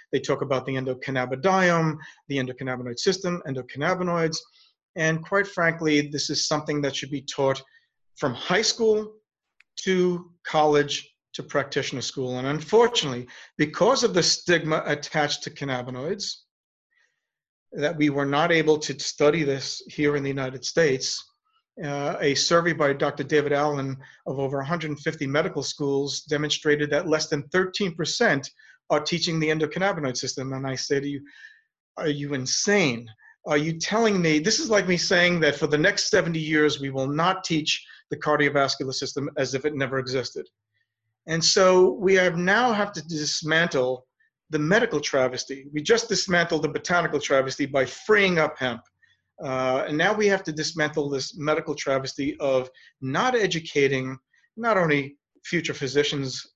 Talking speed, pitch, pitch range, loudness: 155 wpm, 150 Hz, 135-170 Hz, -24 LUFS